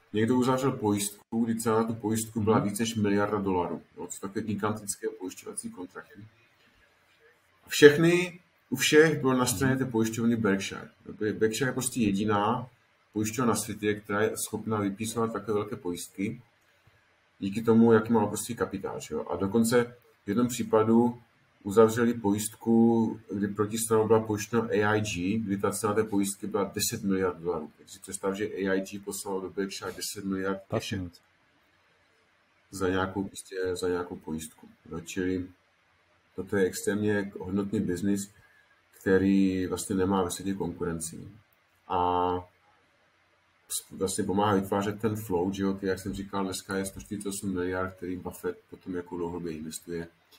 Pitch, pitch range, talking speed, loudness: 105 Hz, 95-115 Hz, 135 wpm, -28 LUFS